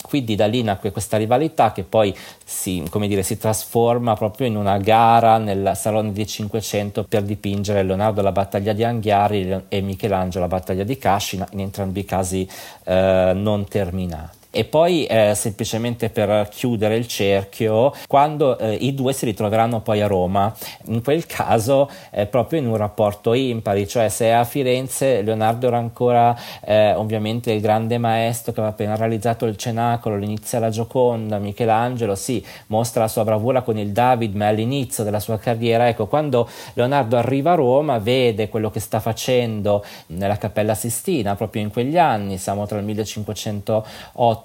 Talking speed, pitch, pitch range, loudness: 165 wpm, 110 Hz, 105-120 Hz, -20 LUFS